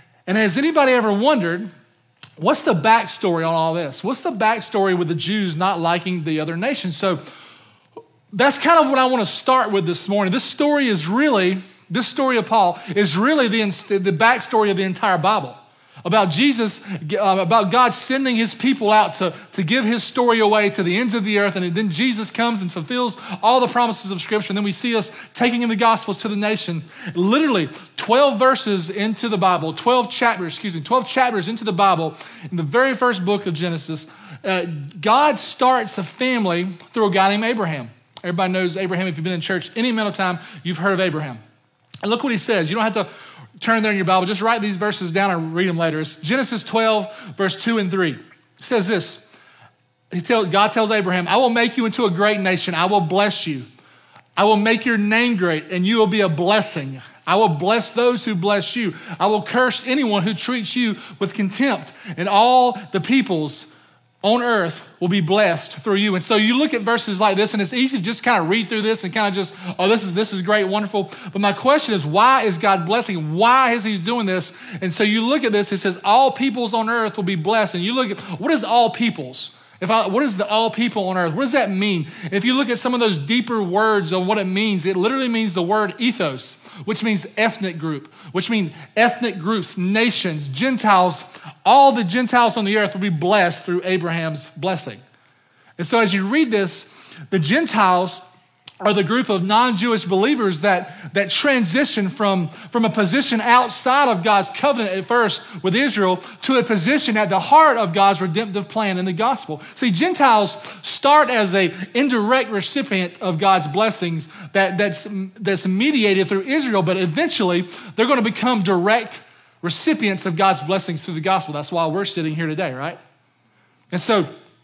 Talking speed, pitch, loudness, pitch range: 205 wpm, 205 Hz, -19 LUFS, 180-230 Hz